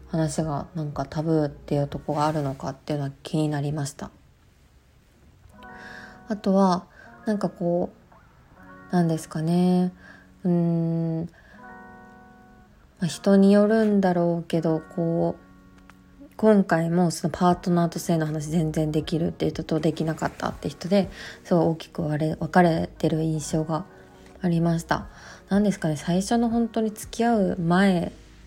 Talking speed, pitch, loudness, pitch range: 285 characters per minute, 165 Hz, -24 LUFS, 155-180 Hz